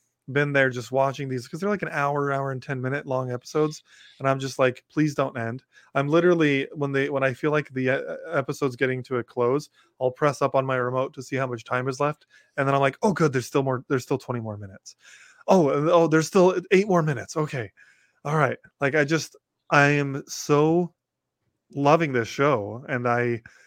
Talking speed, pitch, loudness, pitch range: 215 wpm, 140 Hz, -24 LUFS, 130-150 Hz